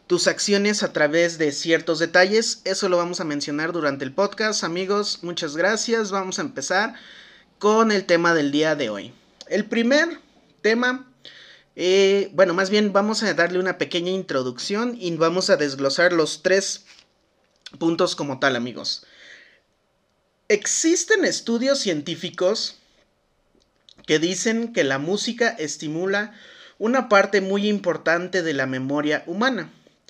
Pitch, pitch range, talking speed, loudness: 185 Hz, 165-210 Hz, 135 wpm, -21 LUFS